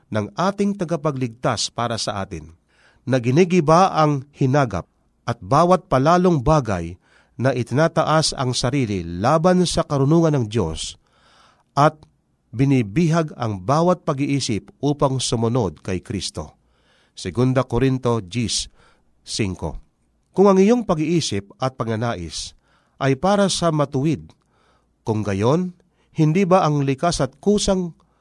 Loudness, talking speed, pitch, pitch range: -20 LUFS, 115 wpm, 135 Hz, 110-165 Hz